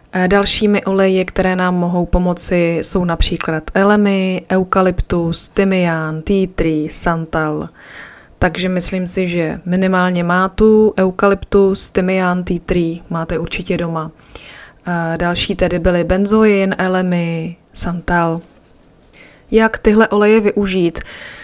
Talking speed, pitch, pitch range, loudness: 105 wpm, 180 Hz, 170-195 Hz, -15 LUFS